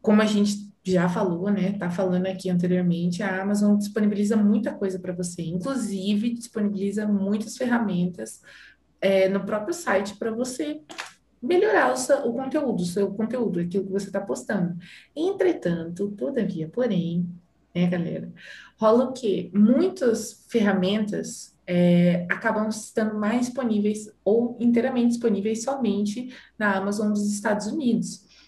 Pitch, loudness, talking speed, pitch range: 205 Hz, -24 LUFS, 135 wpm, 190-230 Hz